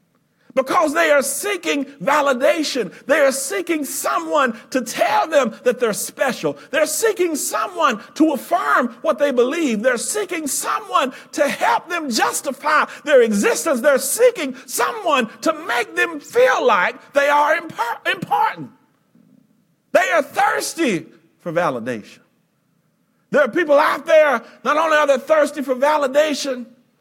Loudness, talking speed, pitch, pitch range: -18 LUFS, 135 wpm, 290 Hz, 265-315 Hz